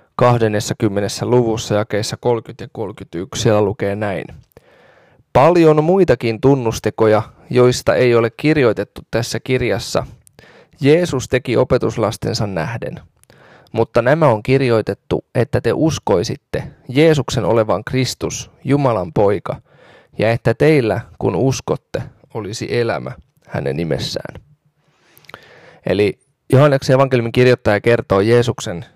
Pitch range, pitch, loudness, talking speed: 110-135 Hz, 120 Hz, -16 LUFS, 100 wpm